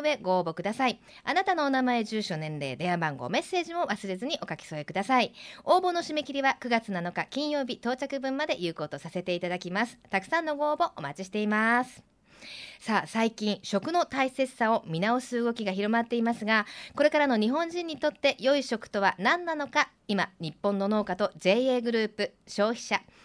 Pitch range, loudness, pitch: 190-275 Hz, -28 LUFS, 225 Hz